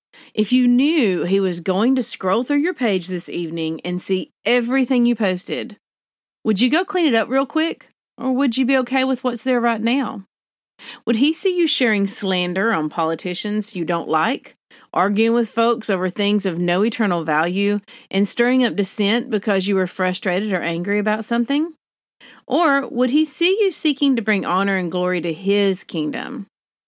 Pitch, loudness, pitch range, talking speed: 215 Hz, -19 LUFS, 185-255 Hz, 185 wpm